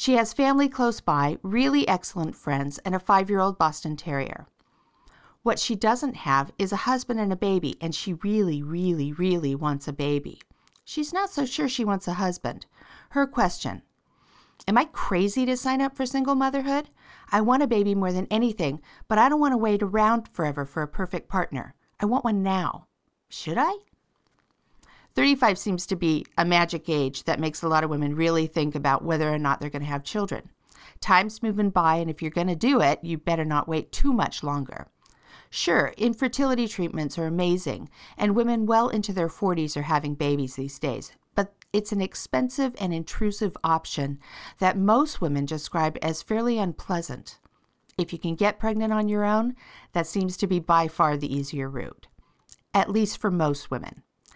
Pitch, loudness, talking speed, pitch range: 185 Hz, -25 LUFS, 190 wpm, 155-220 Hz